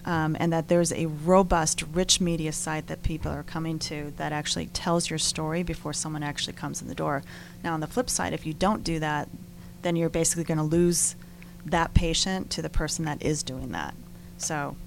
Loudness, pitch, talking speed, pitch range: -27 LUFS, 165 Hz, 210 wpm, 155-170 Hz